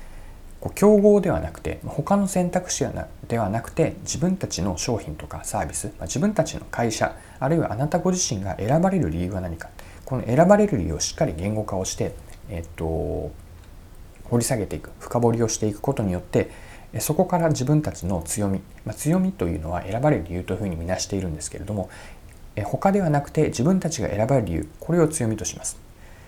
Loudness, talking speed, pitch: -24 LUFS, 385 characters per minute, 110 Hz